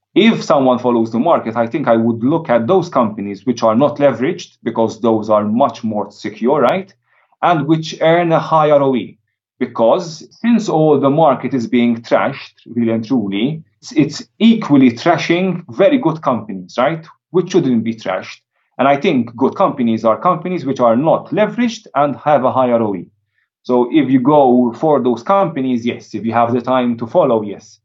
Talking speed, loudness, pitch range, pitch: 180 wpm, -15 LUFS, 115-160 Hz, 130 Hz